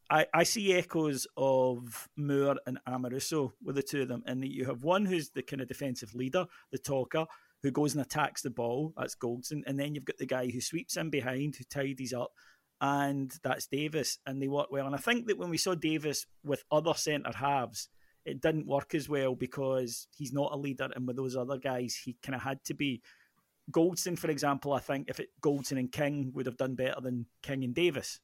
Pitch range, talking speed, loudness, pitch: 130-150 Hz, 220 wpm, -33 LUFS, 140 Hz